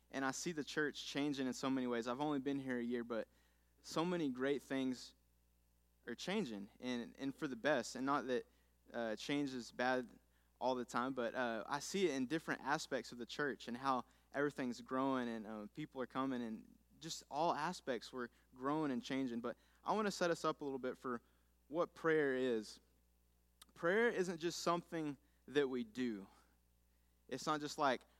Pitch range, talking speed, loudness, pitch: 110-145 Hz, 195 wpm, -41 LUFS, 130 Hz